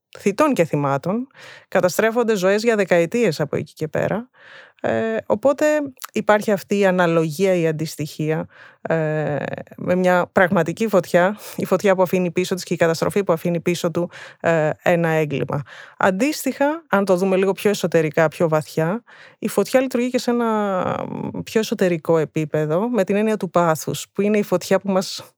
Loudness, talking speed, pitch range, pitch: -20 LUFS, 165 wpm, 165-215 Hz, 185 Hz